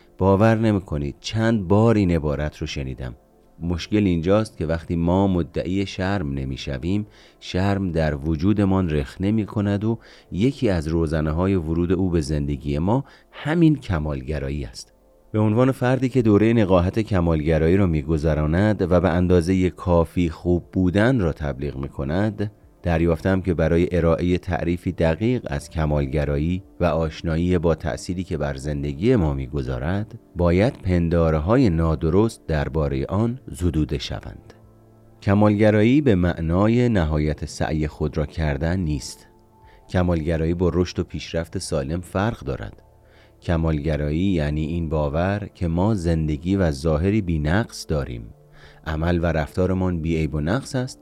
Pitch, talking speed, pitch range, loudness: 85 Hz, 135 wpm, 80-100 Hz, -22 LUFS